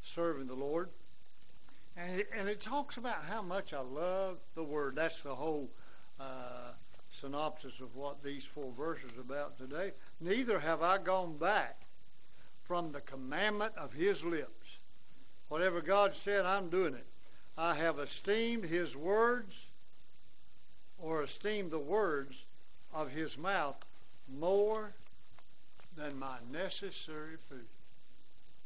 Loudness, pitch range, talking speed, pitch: -37 LUFS, 135-195 Hz, 125 wpm, 160 Hz